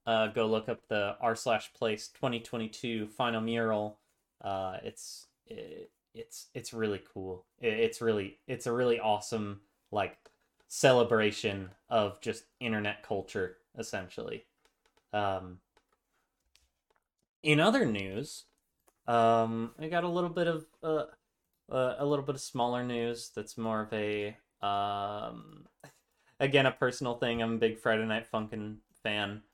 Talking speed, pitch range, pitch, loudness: 135 wpm, 105-130 Hz, 115 Hz, -32 LUFS